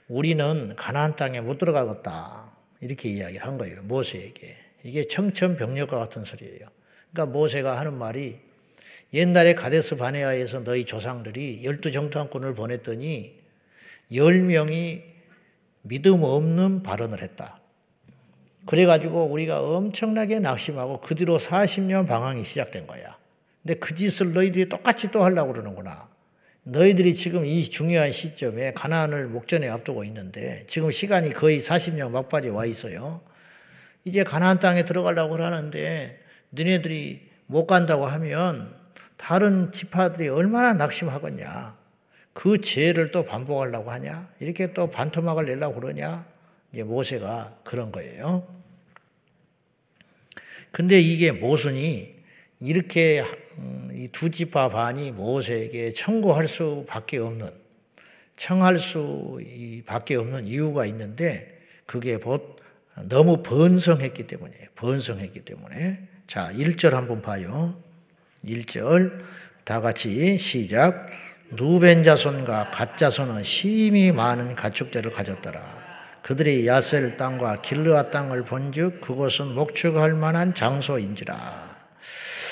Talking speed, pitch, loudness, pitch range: 275 characters per minute, 155 Hz, -23 LUFS, 125-170 Hz